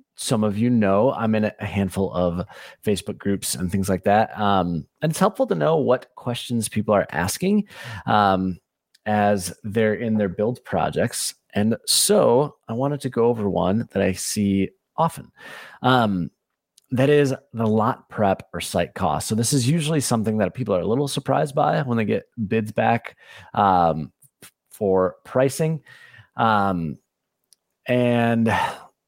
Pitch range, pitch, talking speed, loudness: 100-130 Hz, 110 Hz, 155 wpm, -22 LUFS